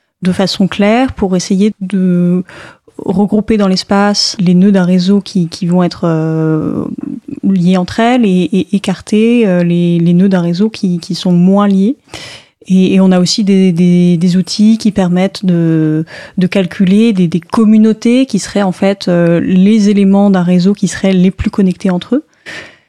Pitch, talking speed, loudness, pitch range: 190 Hz, 175 wpm, -10 LUFS, 180-205 Hz